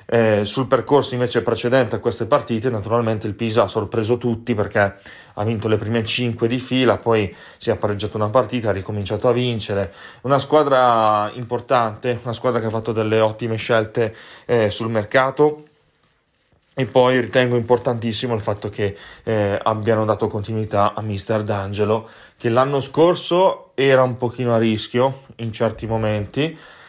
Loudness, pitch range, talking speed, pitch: -20 LUFS, 110-125 Hz, 160 wpm, 115 Hz